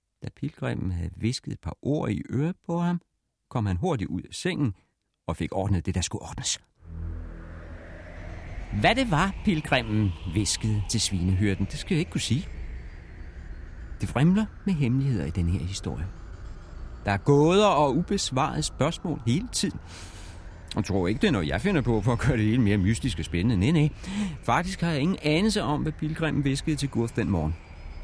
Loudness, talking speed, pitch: -26 LUFS, 185 wpm, 105 Hz